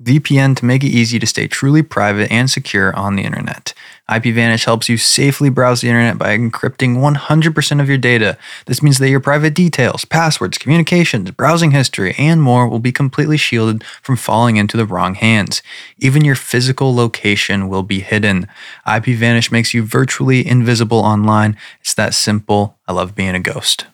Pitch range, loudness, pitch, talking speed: 110-135 Hz, -13 LUFS, 120 Hz, 175 wpm